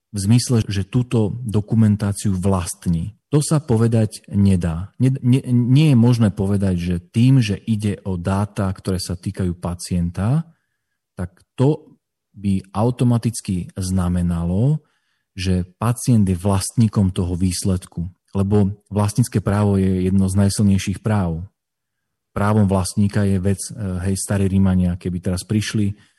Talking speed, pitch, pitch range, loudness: 125 wpm, 100 Hz, 95-110 Hz, -19 LUFS